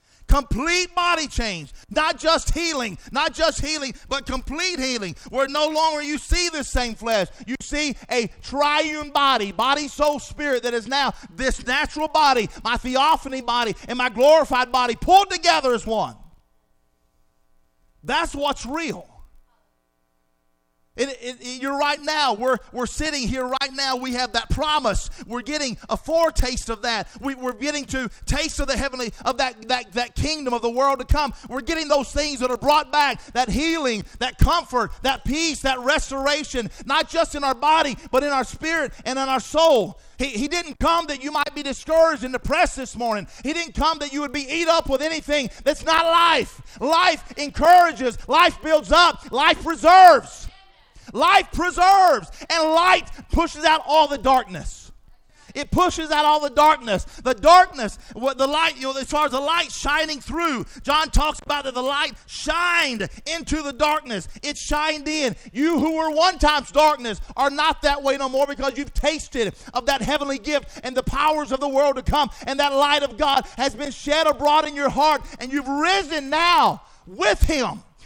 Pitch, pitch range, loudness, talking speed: 285 Hz, 250-310 Hz, -21 LUFS, 185 wpm